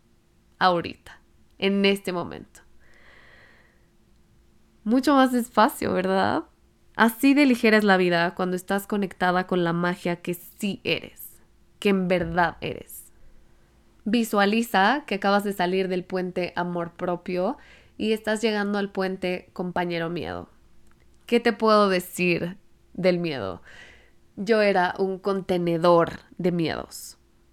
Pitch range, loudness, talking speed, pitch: 180-210 Hz, -24 LUFS, 120 wpm, 190 Hz